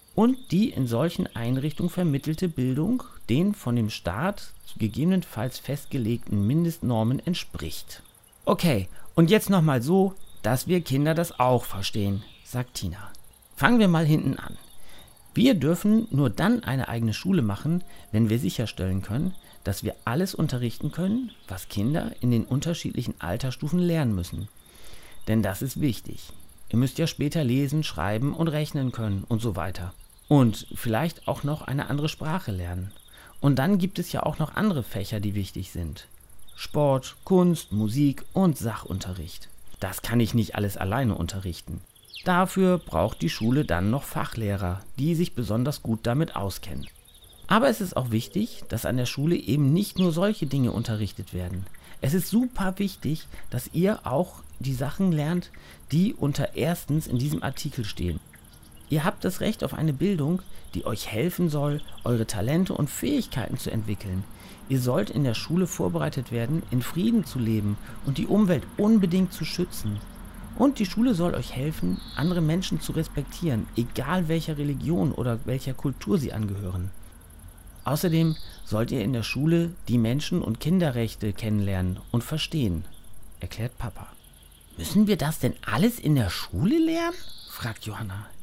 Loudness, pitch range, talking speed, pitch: -26 LUFS, 105-165 Hz, 155 wpm, 130 Hz